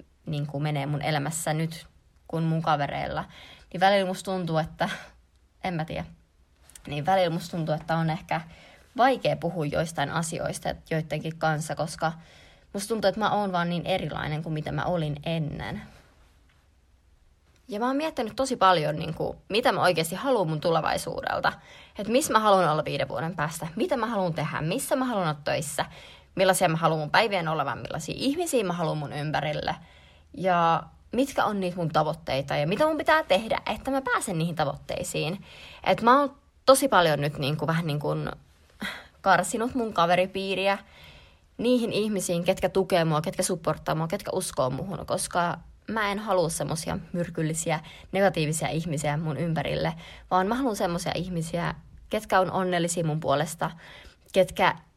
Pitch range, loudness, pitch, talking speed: 150-190 Hz, -27 LUFS, 170 Hz, 160 wpm